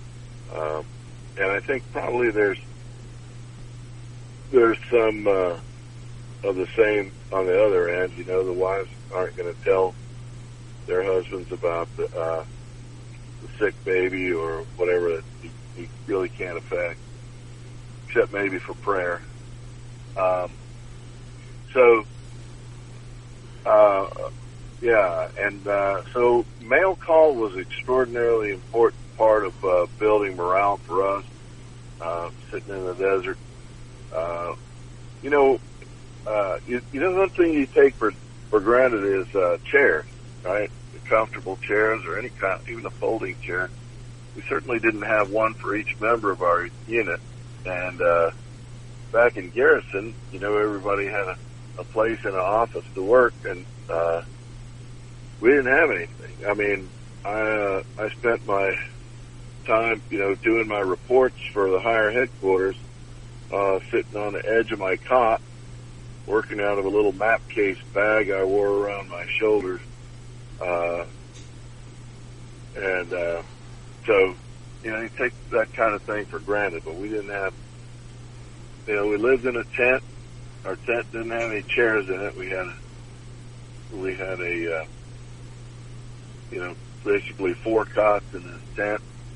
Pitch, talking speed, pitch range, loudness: 120 Hz, 145 wpm, 105-120 Hz, -23 LUFS